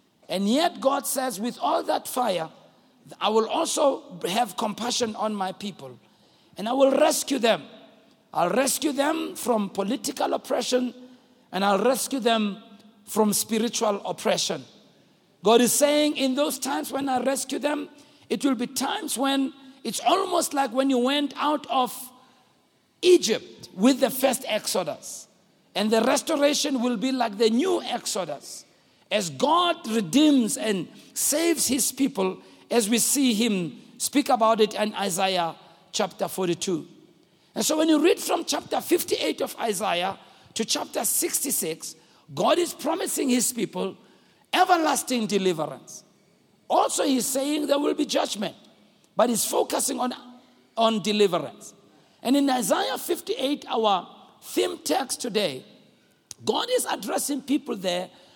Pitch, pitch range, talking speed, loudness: 255 Hz, 220-285 Hz, 140 wpm, -24 LUFS